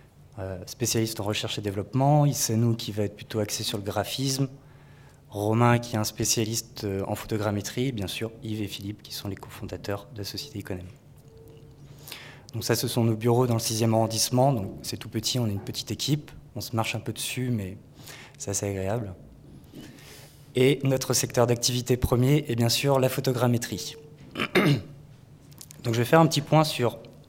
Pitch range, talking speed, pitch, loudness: 110-135 Hz, 180 wpm, 120 Hz, -26 LUFS